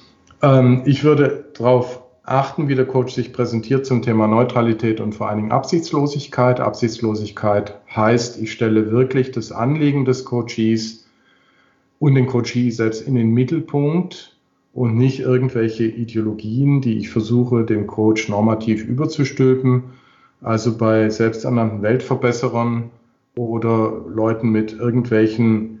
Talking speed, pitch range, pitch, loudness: 120 wpm, 110-130 Hz, 120 Hz, -18 LUFS